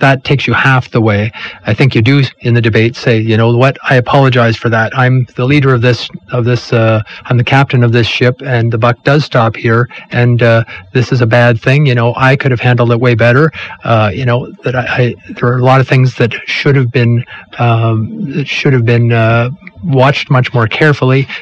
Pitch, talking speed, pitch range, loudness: 125 Hz, 235 wpm, 120-135 Hz, -10 LUFS